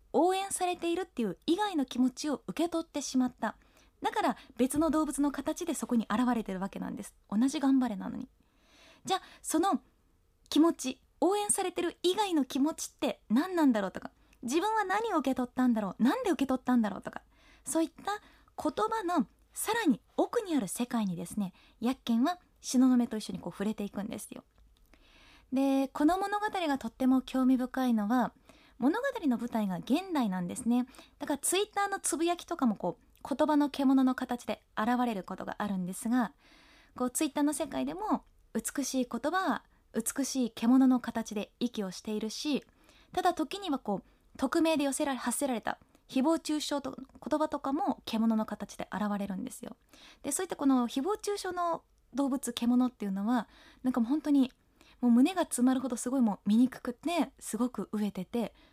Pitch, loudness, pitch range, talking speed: 265 Hz, -31 LUFS, 235-320 Hz, 325 characters per minute